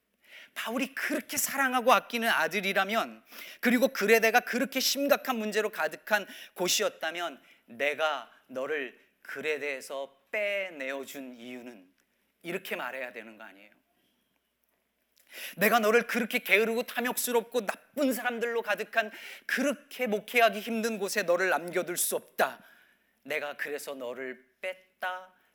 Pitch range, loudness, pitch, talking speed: 160-240 Hz, -29 LUFS, 210 Hz, 290 characters per minute